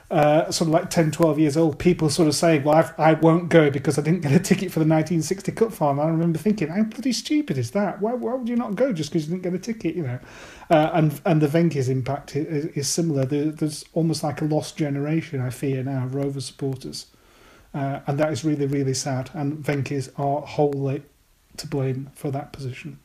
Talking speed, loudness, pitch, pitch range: 230 wpm, -23 LUFS, 155 Hz, 140-170 Hz